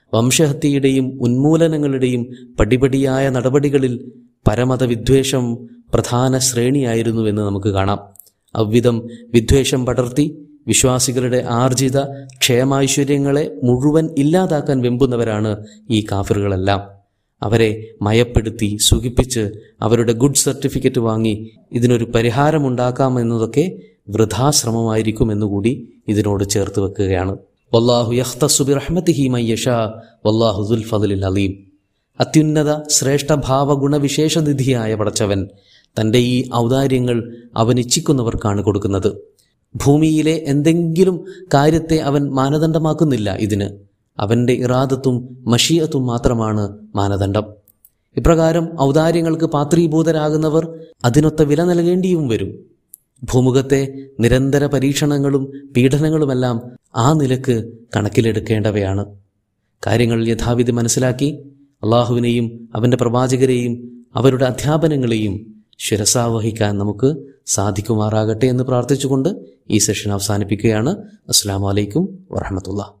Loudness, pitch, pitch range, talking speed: -16 LUFS, 125 Hz, 110-140 Hz, 75 wpm